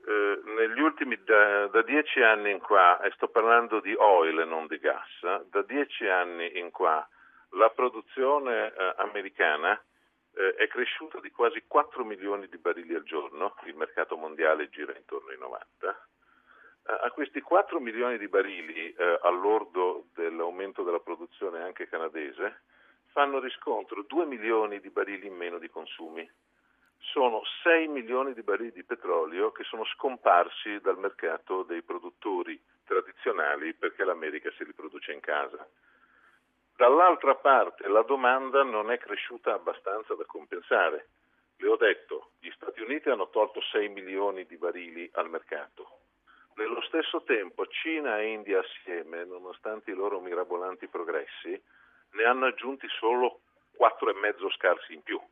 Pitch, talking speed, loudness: 340 Hz, 145 wpm, -28 LUFS